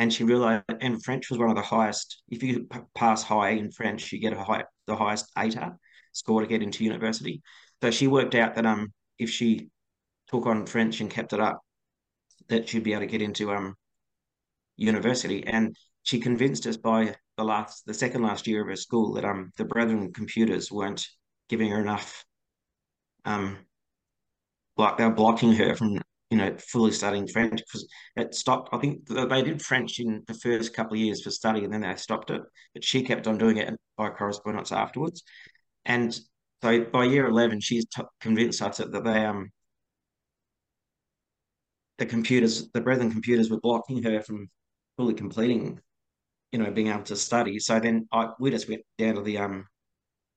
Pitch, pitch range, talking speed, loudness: 110 Hz, 105-120 Hz, 185 wpm, -27 LUFS